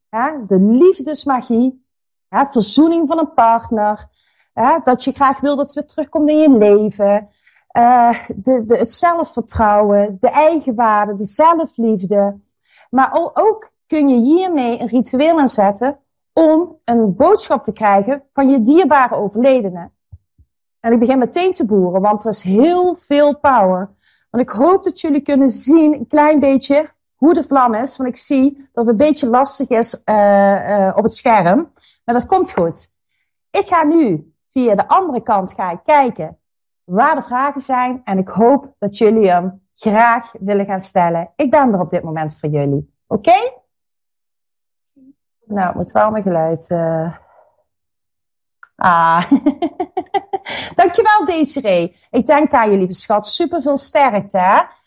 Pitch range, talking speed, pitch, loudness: 205-295 Hz, 155 wpm, 250 Hz, -14 LUFS